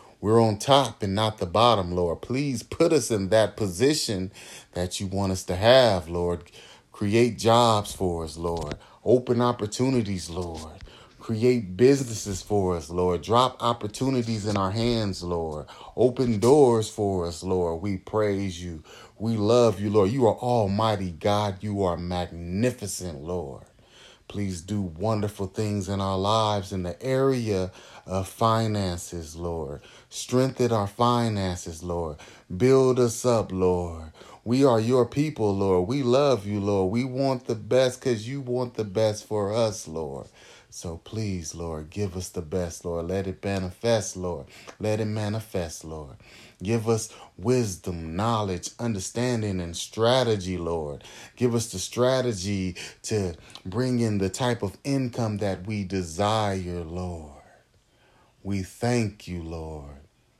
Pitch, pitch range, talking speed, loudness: 105 Hz, 90-115 Hz, 145 wpm, -25 LUFS